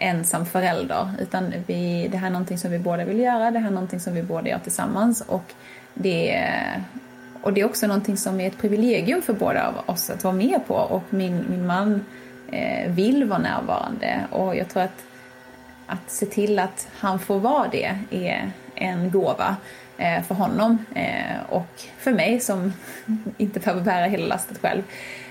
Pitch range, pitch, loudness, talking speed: 180-220 Hz, 195 Hz, -24 LUFS, 180 wpm